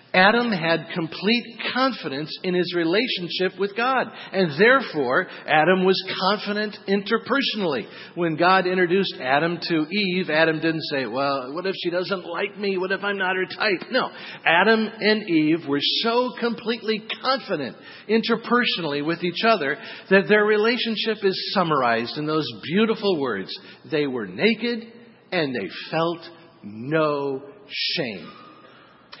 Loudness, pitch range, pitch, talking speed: -22 LUFS, 165-220 Hz, 190 Hz, 135 wpm